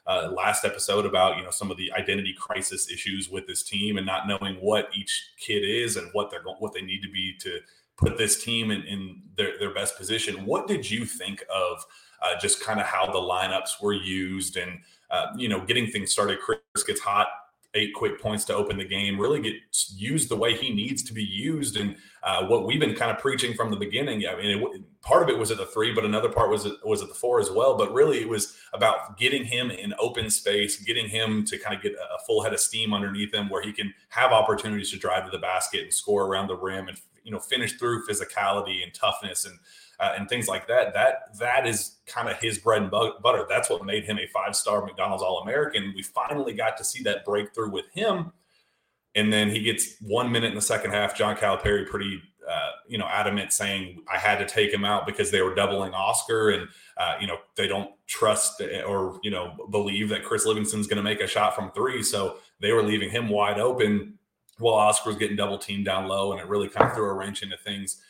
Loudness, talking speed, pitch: -26 LUFS, 230 wpm, 105 Hz